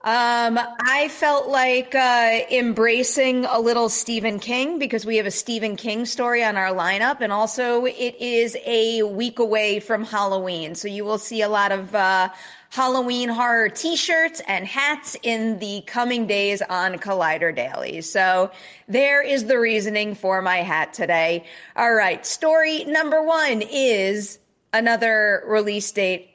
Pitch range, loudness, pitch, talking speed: 200-250 Hz, -20 LUFS, 225 Hz, 155 wpm